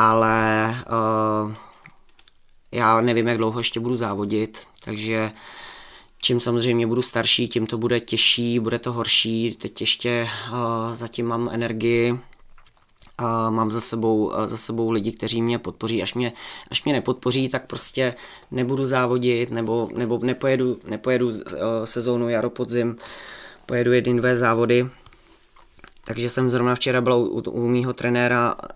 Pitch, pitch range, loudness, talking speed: 120 Hz, 115-125 Hz, -22 LUFS, 140 wpm